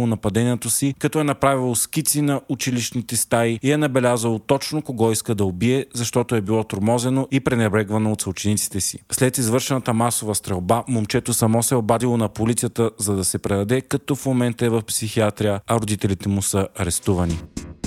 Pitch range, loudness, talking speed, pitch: 105-130 Hz, -21 LUFS, 175 wpm, 115 Hz